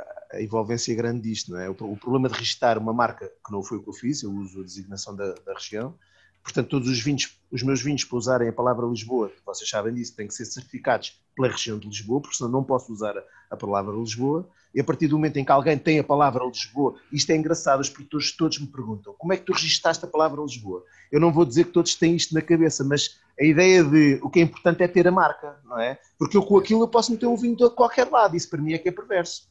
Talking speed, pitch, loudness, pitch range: 260 wpm, 145 Hz, -23 LUFS, 120-170 Hz